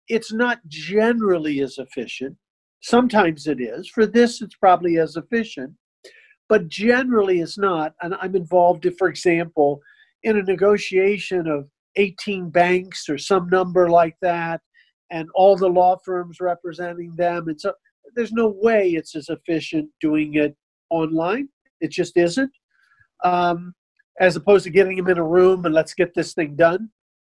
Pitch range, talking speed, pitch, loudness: 165-200 Hz, 155 wpm, 180 Hz, -20 LUFS